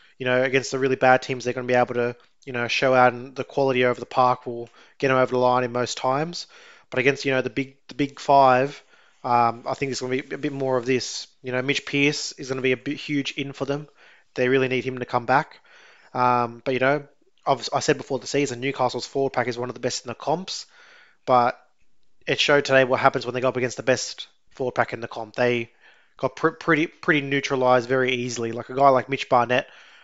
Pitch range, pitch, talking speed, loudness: 125-140 Hz, 130 Hz, 255 wpm, -23 LUFS